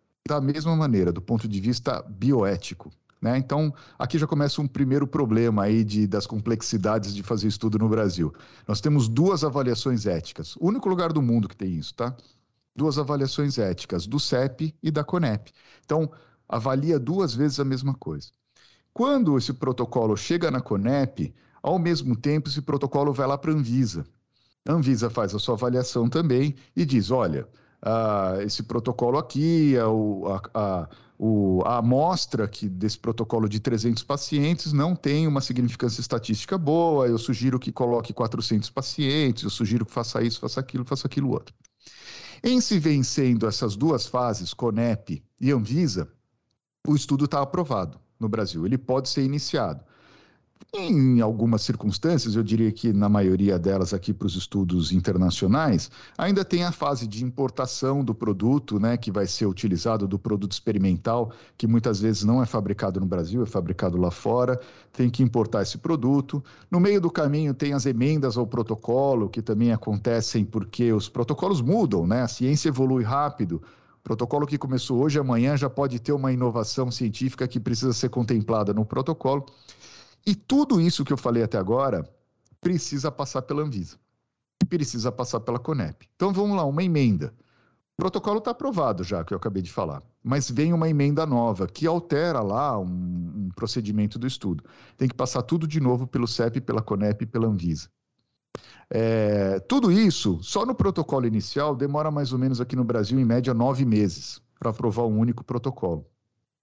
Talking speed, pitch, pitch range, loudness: 170 wpm, 125 Hz, 110-145 Hz, -25 LUFS